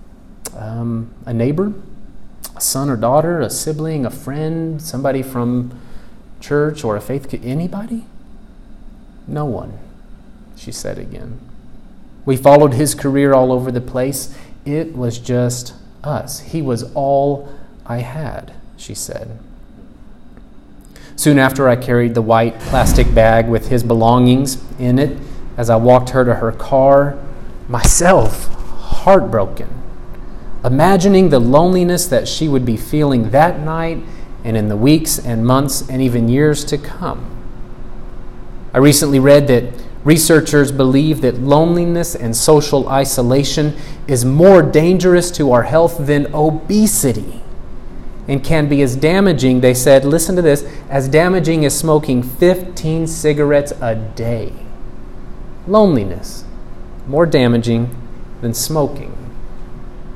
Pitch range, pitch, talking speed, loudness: 125-155 Hz, 140 Hz, 125 wpm, -14 LUFS